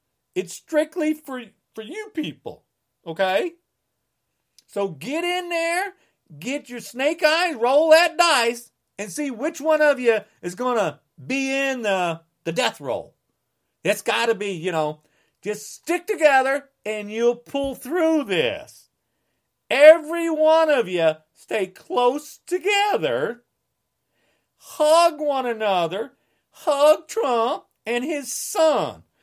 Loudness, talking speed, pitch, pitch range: -21 LUFS, 125 wpm, 275 Hz, 210-320 Hz